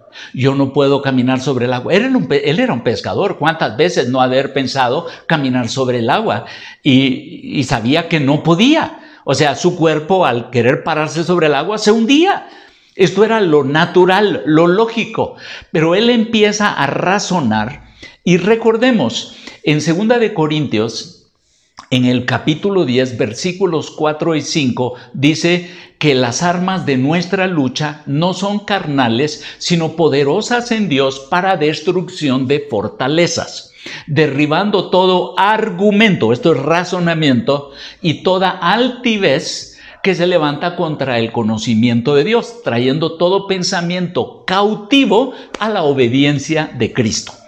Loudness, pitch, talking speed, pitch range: -14 LUFS, 160 Hz, 135 wpm, 135-190 Hz